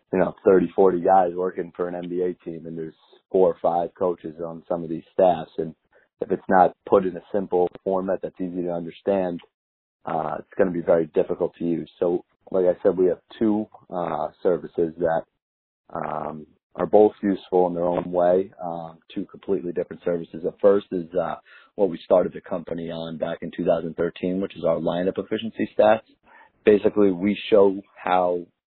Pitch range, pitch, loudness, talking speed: 85-95 Hz, 90 Hz, -23 LUFS, 185 wpm